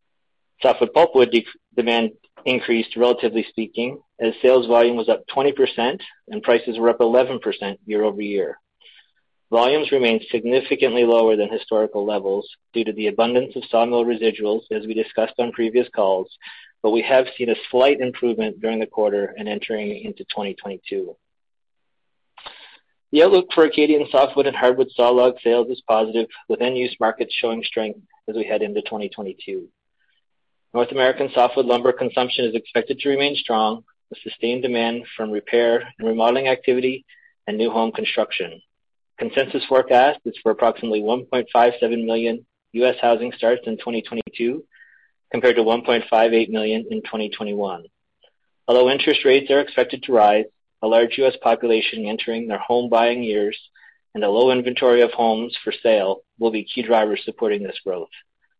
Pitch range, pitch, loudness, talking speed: 110-130 Hz, 120 Hz, -20 LUFS, 150 wpm